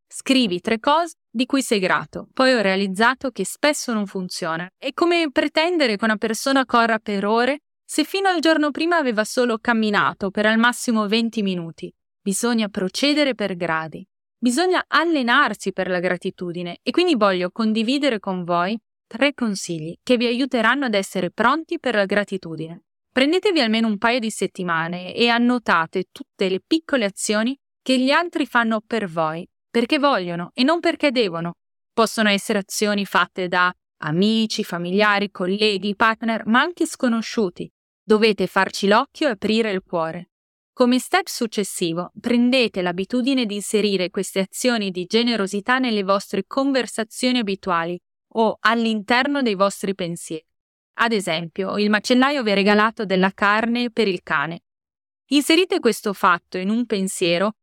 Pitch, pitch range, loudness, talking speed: 220 Hz, 195-255 Hz, -20 LUFS, 150 wpm